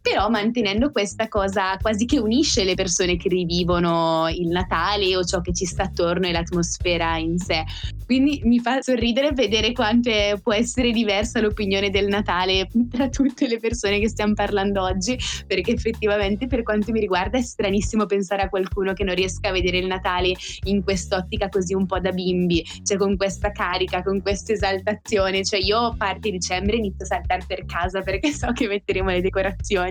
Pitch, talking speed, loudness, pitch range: 200 Hz, 185 wpm, -22 LUFS, 185-220 Hz